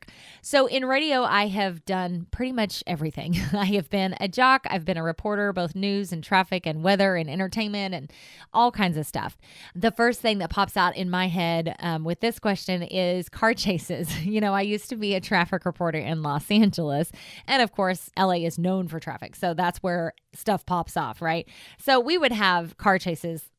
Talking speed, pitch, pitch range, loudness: 205 wpm, 185 Hz, 170-205 Hz, -25 LUFS